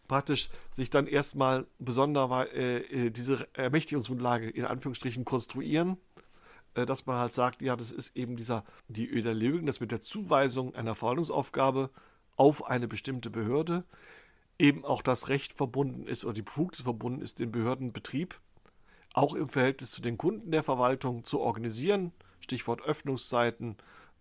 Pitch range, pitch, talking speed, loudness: 120-140 Hz, 130 Hz, 145 wpm, -31 LUFS